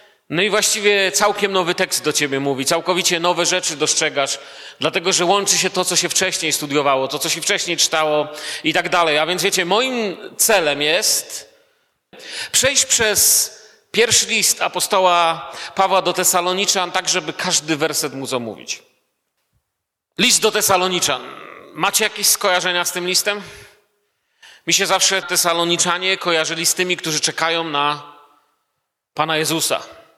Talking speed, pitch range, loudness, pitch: 140 wpm, 160-200 Hz, -16 LUFS, 180 Hz